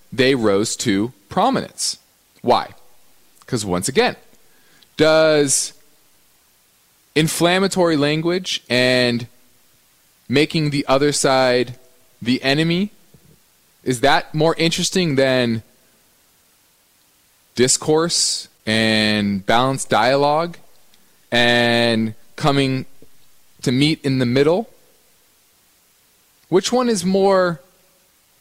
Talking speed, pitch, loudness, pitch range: 80 wpm, 140 Hz, -18 LUFS, 125-165 Hz